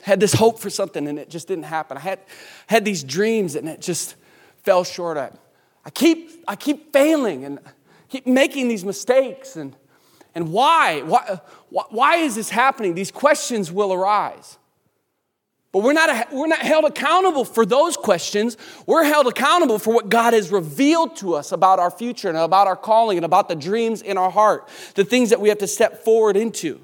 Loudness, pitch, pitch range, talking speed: -19 LUFS, 210 Hz, 185-255 Hz, 195 wpm